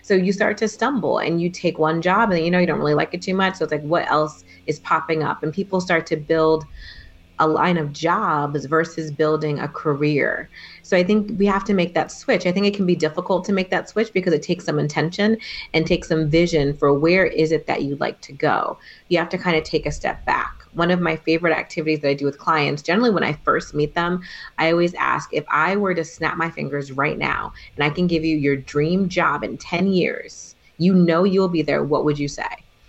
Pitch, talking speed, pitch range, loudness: 165 Hz, 245 wpm, 155-180 Hz, -20 LUFS